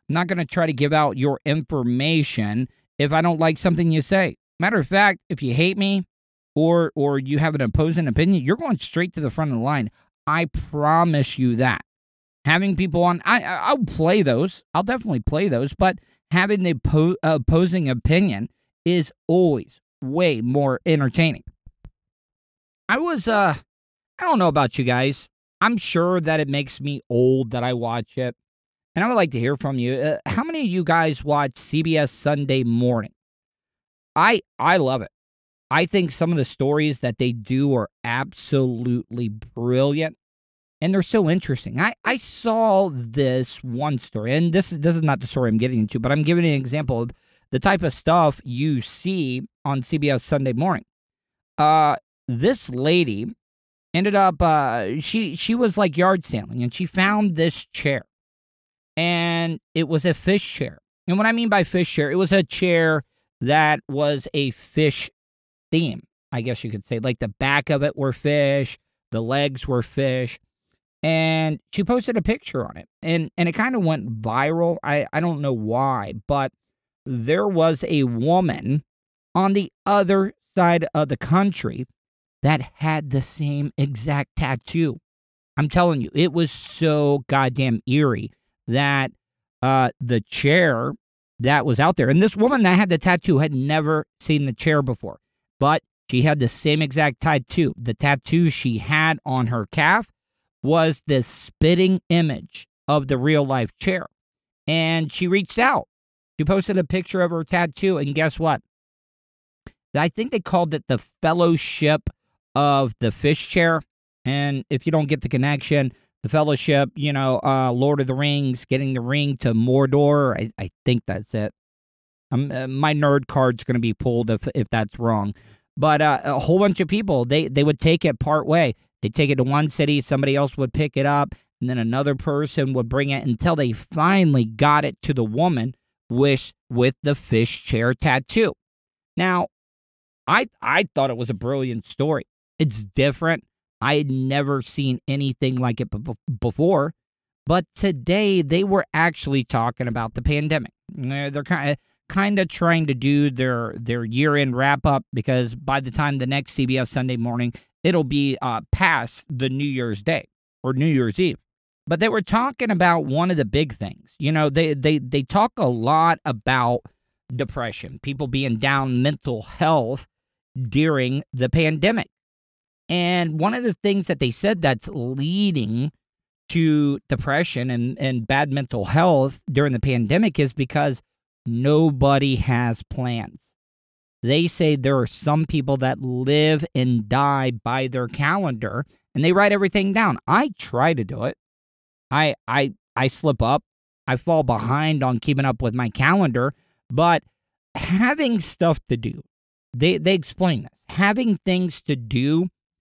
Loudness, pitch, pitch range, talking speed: -21 LUFS, 145 Hz, 125-165 Hz, 170 wpm